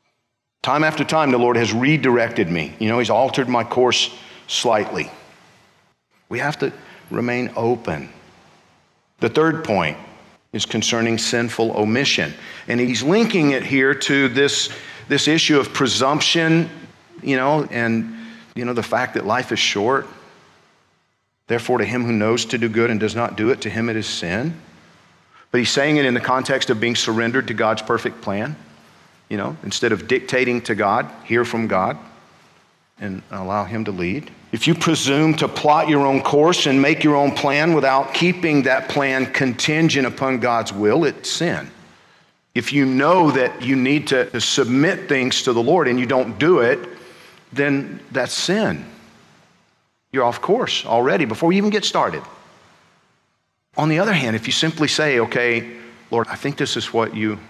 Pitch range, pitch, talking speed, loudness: 115-145 Hz, 125 Hz, 170 wpm, -19 LUFS